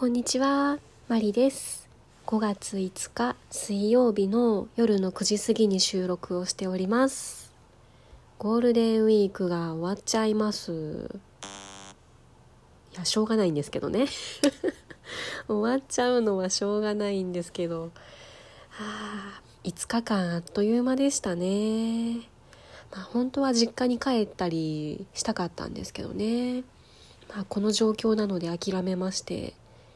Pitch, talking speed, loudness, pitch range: 210 Hz, 265 characters per minute, -27 LUFS, 185-235 Hz